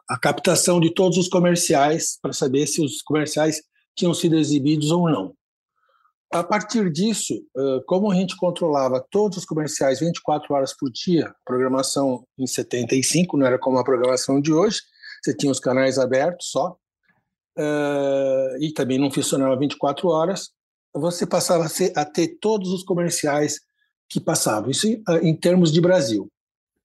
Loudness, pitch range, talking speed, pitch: -21 LUFS, 140-180 Hz, 150 wpm, 160 Hz